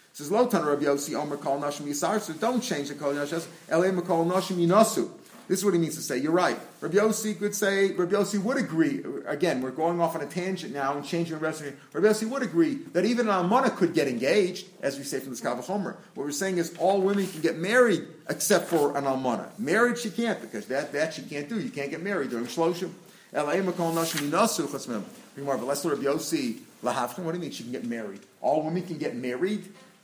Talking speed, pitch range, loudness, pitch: 175 wpm, 150-205 Hz, -27 LUFS, 180 Hz